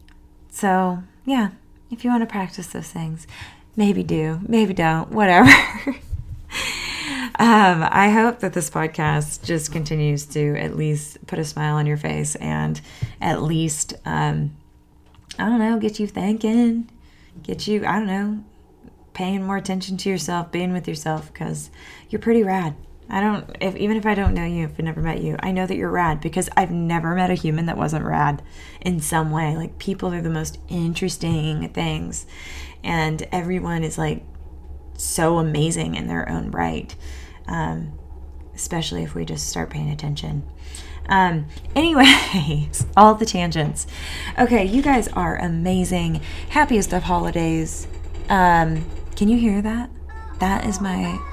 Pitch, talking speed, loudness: 165 Hz, 160 wpm, -20 LUFS